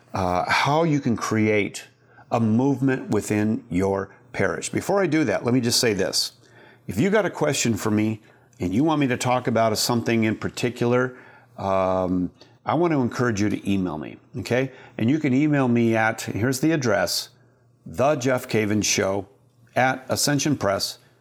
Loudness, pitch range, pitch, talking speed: -23 LUFS, 105-130 Hz, 120 Hz, 175 wpm